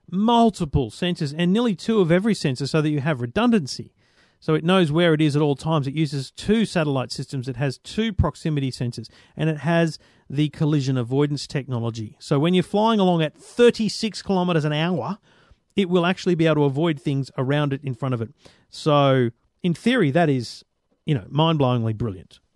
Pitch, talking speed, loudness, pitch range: 155 Hz, 190 wpm, -22 LUFS, 135-180 Hz